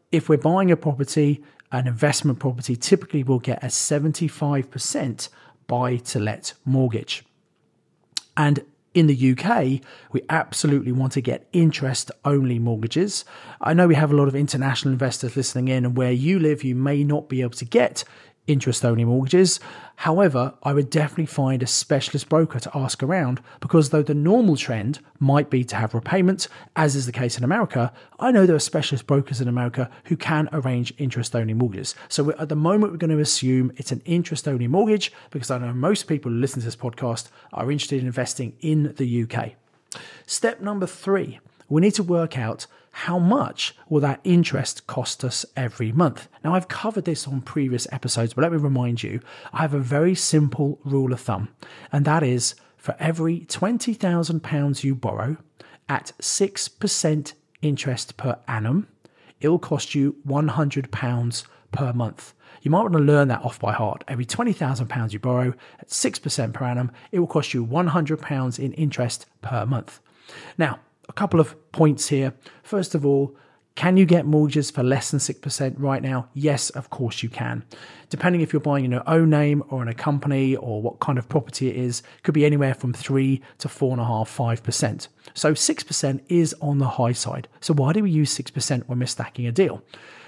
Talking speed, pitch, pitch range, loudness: 185 wpm, 140 Hz, 125-155 Hz, -22 LUFS